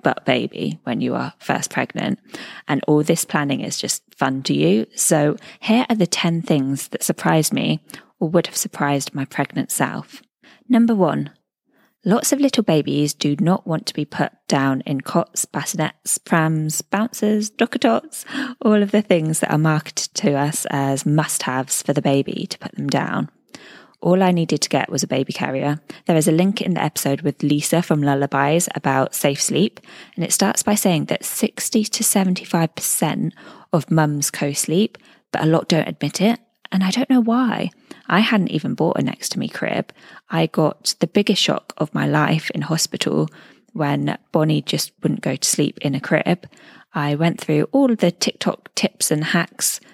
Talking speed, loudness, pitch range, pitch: 185 wpm, -20 LUFS, 145-215 Hz, 170 Hz